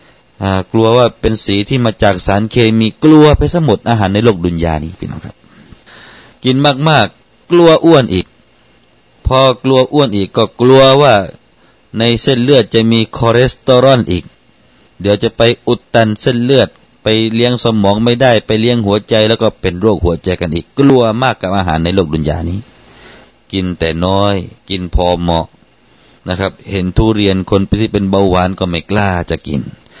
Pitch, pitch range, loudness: 110 Hz, 95-120 Hz, -11 LUFS